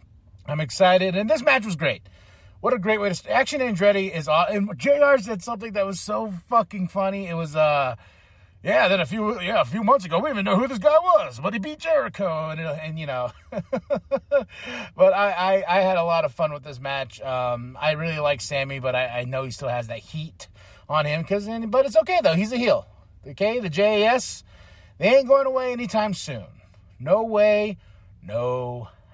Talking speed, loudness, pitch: 210 wpm, -22 LUFS, 180 Hz